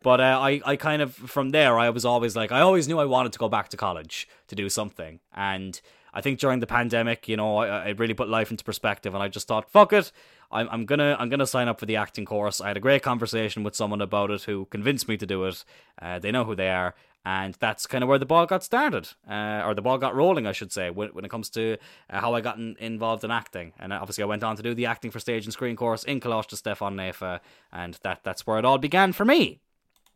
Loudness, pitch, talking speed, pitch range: -25 LUFS, 115 Hz, 275 wpm, 105-130 Hz